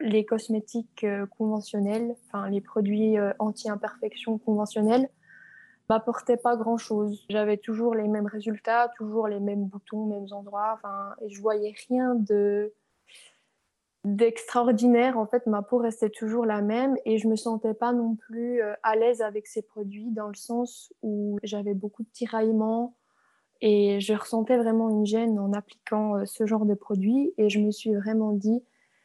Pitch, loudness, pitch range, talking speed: 220 Hz, -27 LUFS, 210-235 Hz, 155 wpm